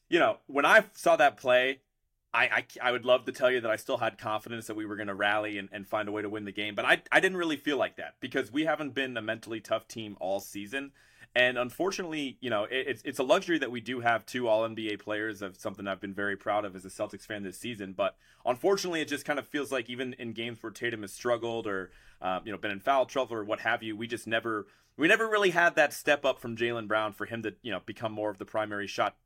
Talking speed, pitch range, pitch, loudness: 275 wpm, 105-130 Hz, 115 Hz, -30 LUFS